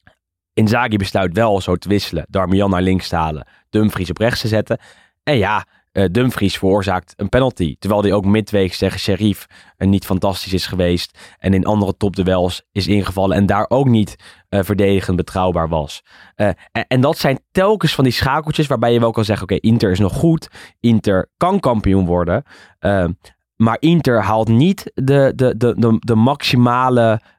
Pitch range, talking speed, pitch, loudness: 95-120 Hz, 180 wpm, 105 Hz, -16 LUFS